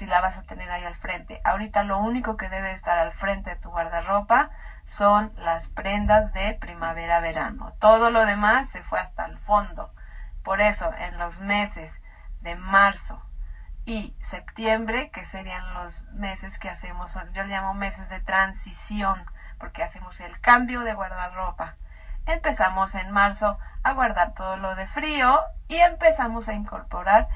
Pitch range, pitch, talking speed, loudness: 185-220 Hz, 195 Hz, 160 wpm, -24 LUFS